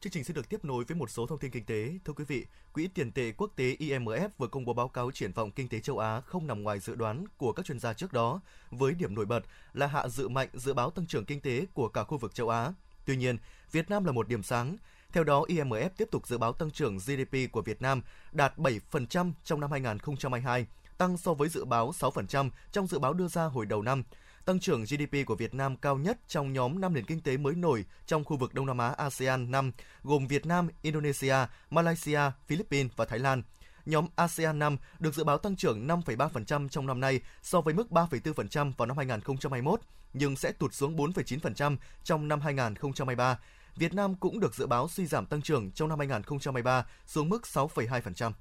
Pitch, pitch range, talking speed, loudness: 140 Hz, 125-160 Hz, 225 wpm, -32 LUFS